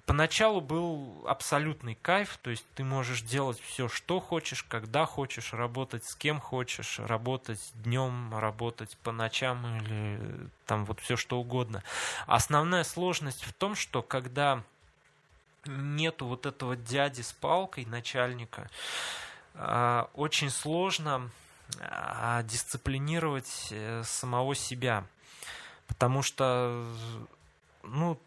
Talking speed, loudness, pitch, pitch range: 105 wpm, -32 LUFS, 125 Hz, 115-140 Hz